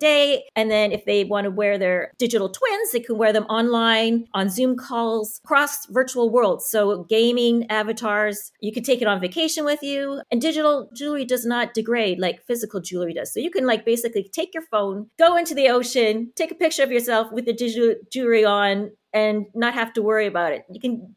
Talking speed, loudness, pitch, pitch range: 210 wpm, -21 LUFS, 230 Hz, 210-255 Hz